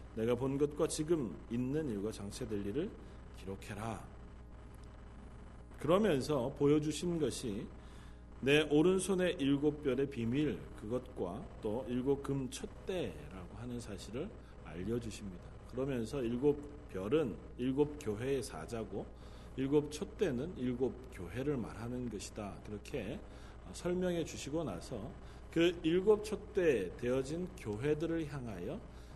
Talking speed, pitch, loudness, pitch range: 250 characters per minute, 125 Hz, -37 LUFS, 105-150 Hz